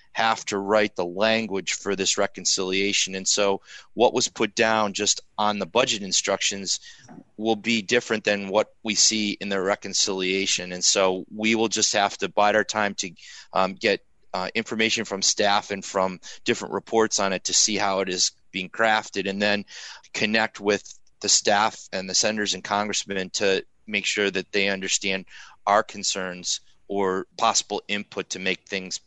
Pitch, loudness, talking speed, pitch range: 100 Hz, -23 LUFS, 175 wpm, 95-105 Hz